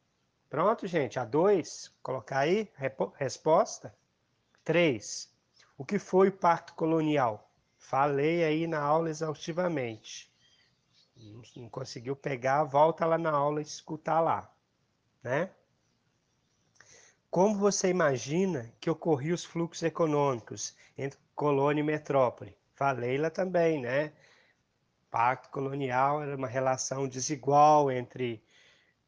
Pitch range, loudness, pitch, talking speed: 135-165 Hz, -29 LUFS, 150 Hz, 110 wpm